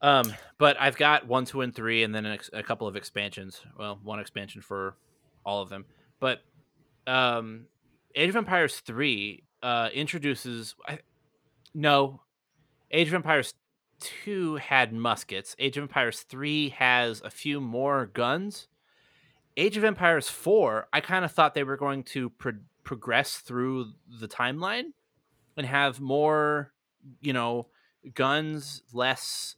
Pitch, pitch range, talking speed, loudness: 135 Hz, 120-150 Hz, 145 wpm, -27 LUFS